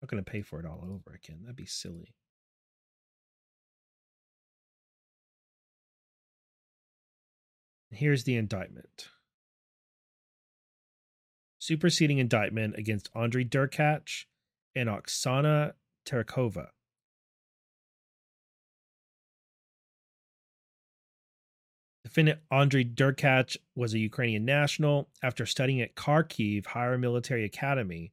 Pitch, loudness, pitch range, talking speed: 125 Hz, -29 LUFS, 110-140 Hz, 80 wpm